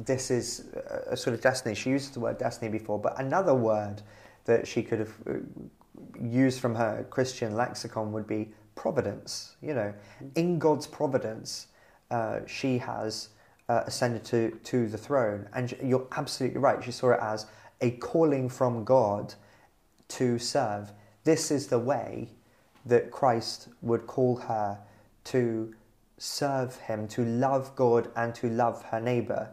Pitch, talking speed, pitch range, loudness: 120 Hz, 150 wpm, 110-130 Hz, -29 LUFS